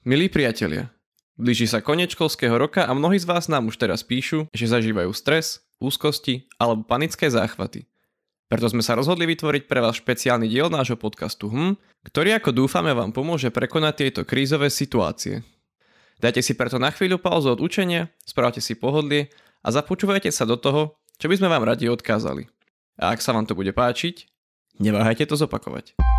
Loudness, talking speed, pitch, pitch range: -22 LUFS, 170 wpm, 135 Hz, 115-160 Hz